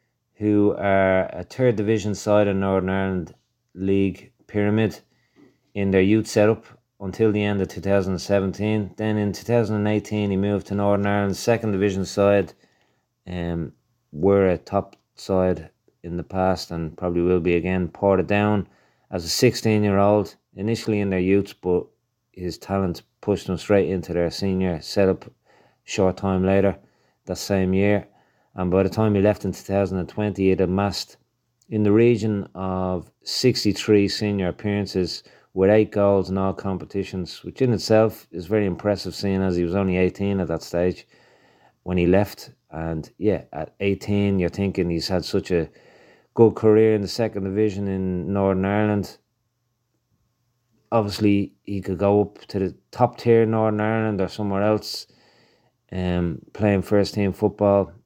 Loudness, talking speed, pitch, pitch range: -22 LUFS, 160 wpm, 100 Hz, 95-105 Hz